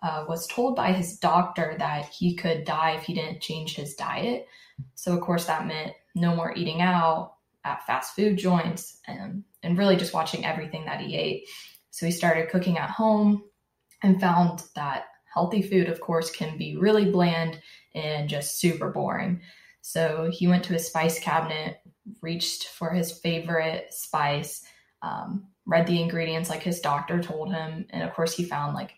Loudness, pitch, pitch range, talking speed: -27 LUFS, 170 Hz, 160-180 Hz, 180 wpm